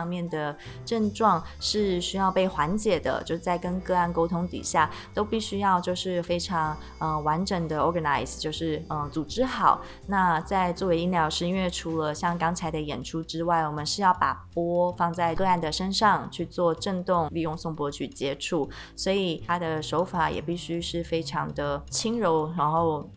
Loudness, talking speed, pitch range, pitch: -27 LUFS, 280 characters per minute, 160-185 Hz, 170 Hz